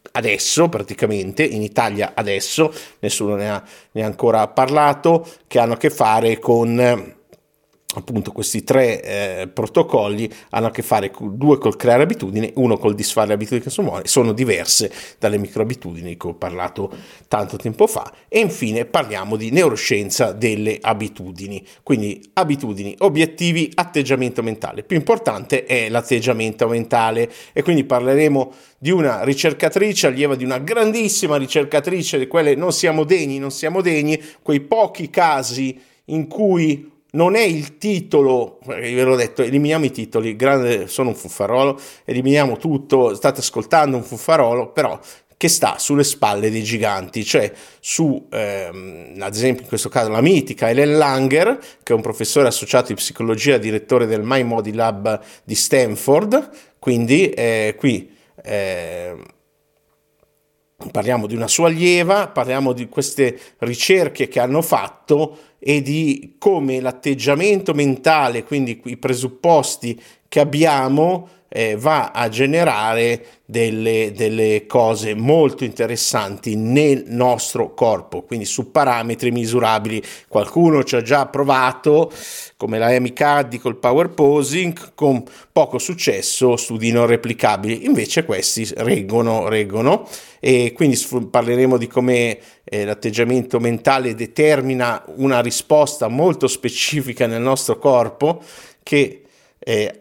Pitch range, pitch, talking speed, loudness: 115-150 Hz, 130 Hz, 135 wpm, -18 LUFS